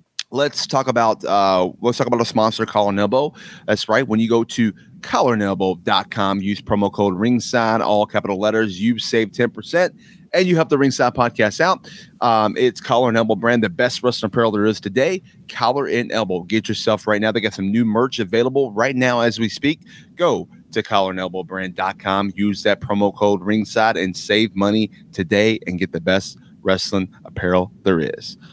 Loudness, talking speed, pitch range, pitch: -19 LUFS, 185 wpm, 100-120 Hz, 110 Hz